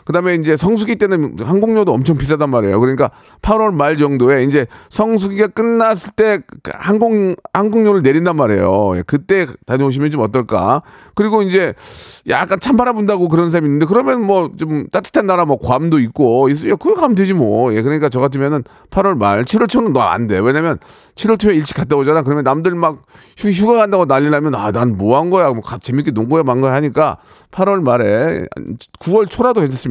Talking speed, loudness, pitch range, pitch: 375 characters per minute, -14 LUFS, 140-210 Hz, 165 Hz